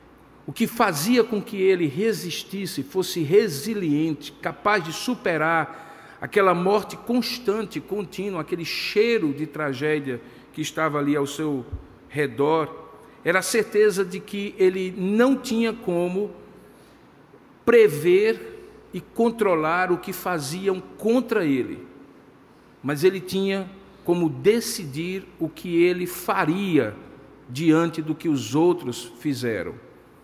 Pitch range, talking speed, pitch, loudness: 155-205 Hz, 115 wpm, 180 Hz, -23 LUFS